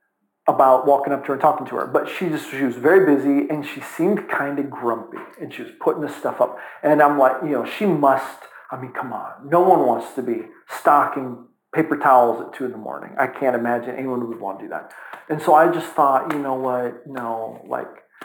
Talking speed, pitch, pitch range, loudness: 235 wpm, 135 Hz, 125-150 Hz, -20 LUFS